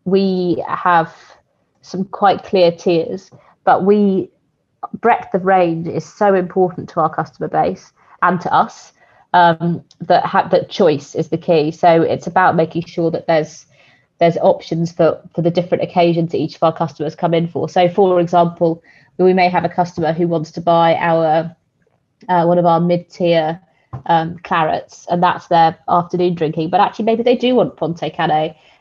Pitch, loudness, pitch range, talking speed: 170 Hz, -16 LUFS, 160-180 Hz, 175 wpm